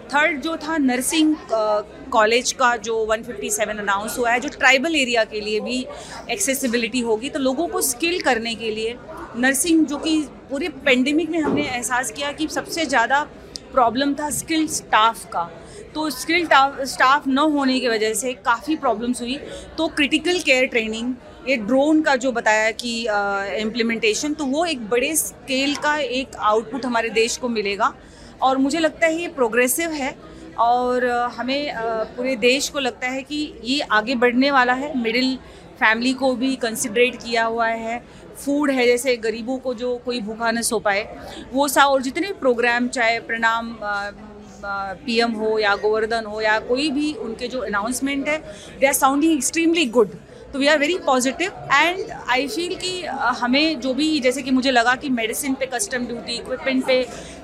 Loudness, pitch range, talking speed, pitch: -20 LUFS, 230-285 Hz, 170 wpm, 255 Hz